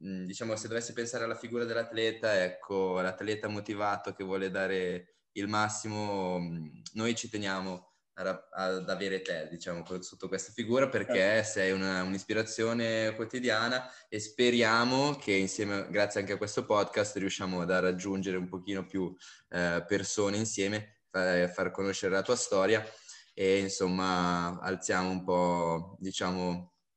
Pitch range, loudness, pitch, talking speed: 95-110 Hz, -32 LUFS, 95 Hz, 130 wpm